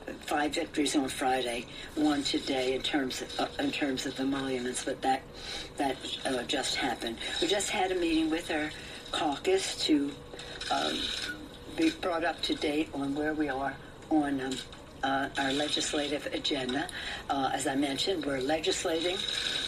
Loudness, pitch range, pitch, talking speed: -31 LUFS, 135-160 Hz, 145 Hz, 155 wpm